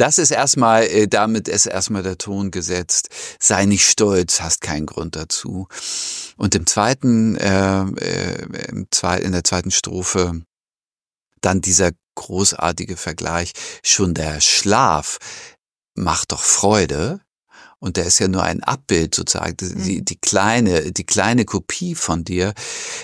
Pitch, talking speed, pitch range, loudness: 95 Hz, 130 wpm, 90-100 Hz, -17 LUFS